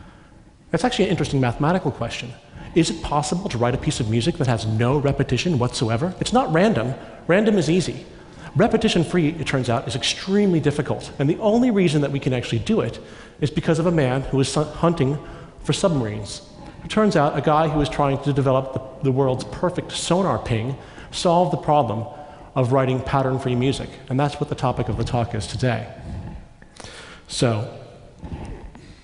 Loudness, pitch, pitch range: -21 LUFS, 140 Hz, 125-165 Hz